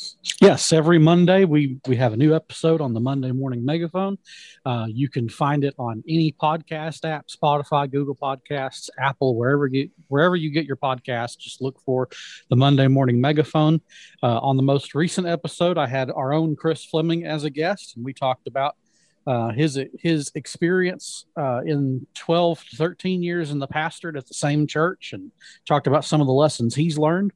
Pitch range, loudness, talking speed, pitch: 135-165 Hz, -22 LUFS, 185 wpm, 150 Hz